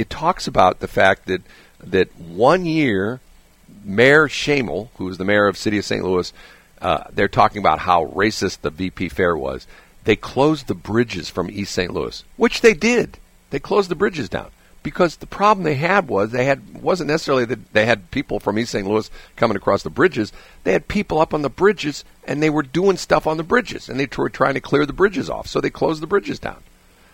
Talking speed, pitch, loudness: 220 wpm, 140 Hz, -19 LUFS